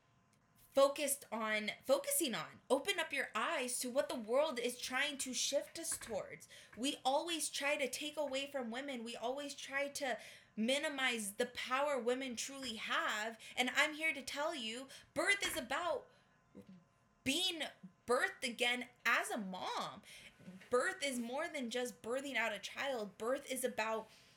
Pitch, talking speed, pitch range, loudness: 260 Hz, 155 wpm, 240-285 Hz, -38 LUFS